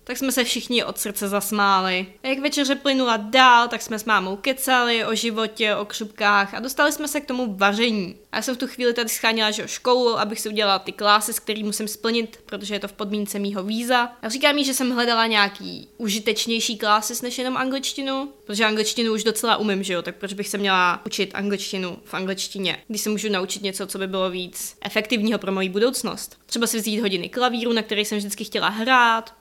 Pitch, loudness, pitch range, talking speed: 220 Hz, -22 LUFS, 205-240 Hz, 220 wpm